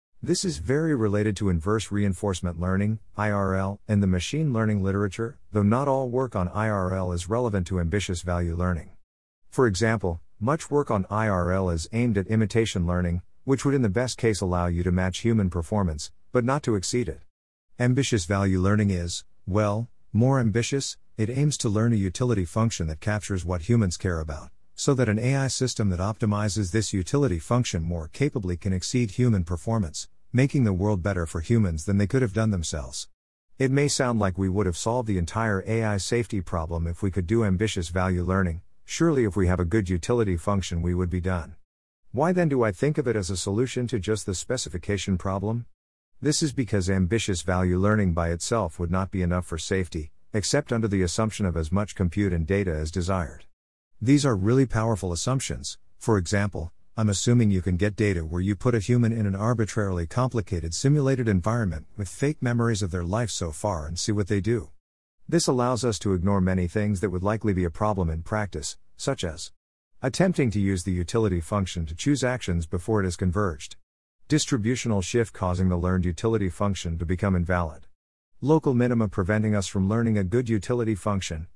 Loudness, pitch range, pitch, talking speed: -25 LUFS, 90-115 Hz, 100 Hz, 195 wpm